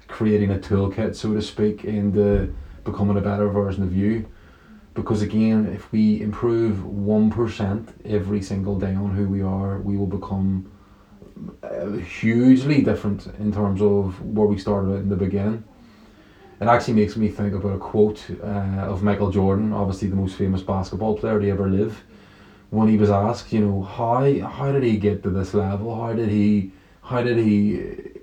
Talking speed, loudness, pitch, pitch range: 175 wpm, -22 LUFS, 105 Hz, 100-110 Hz